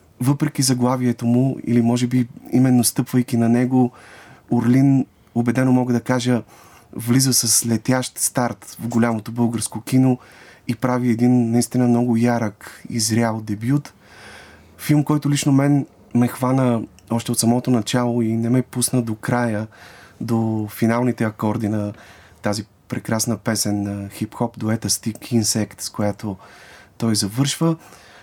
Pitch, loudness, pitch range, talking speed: 120 Hz, -20 LUFS, 110-125 Hz, 135 wpm